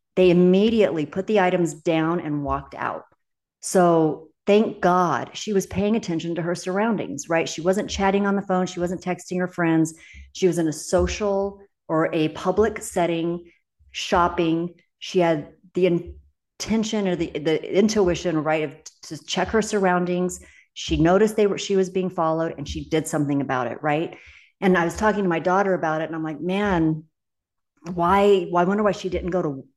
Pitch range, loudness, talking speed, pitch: 160-190 Hz, -22 LUFS, 185 wpm, 175 Hz